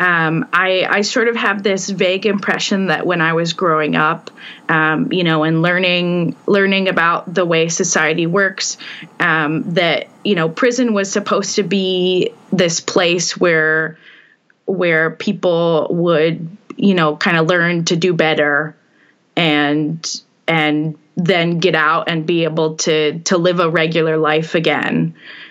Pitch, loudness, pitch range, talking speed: 175 Hz, -15 LUFS, 160-190 Hz, 150 wpm